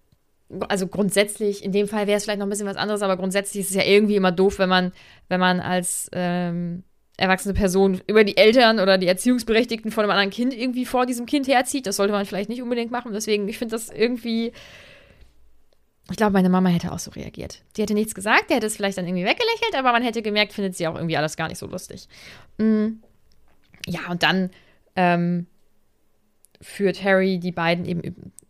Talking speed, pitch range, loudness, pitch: 205 wpm, 180-220 Hz, -21 LUFS, 195 Hz